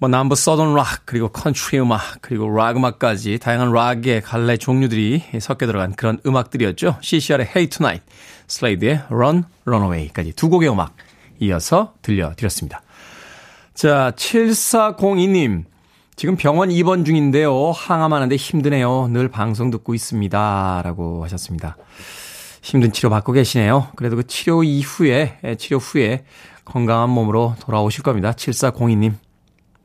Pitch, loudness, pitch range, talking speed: 125 Hz, -18 LUFS, 110-145 Hz, 340 characters per minute